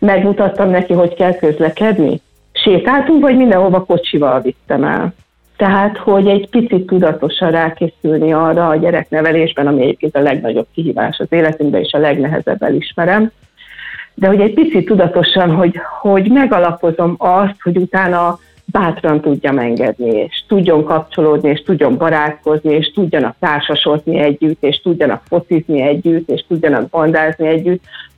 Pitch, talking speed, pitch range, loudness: 170 Hz, 135 wpm, 155-190 Hz, -13 LUFS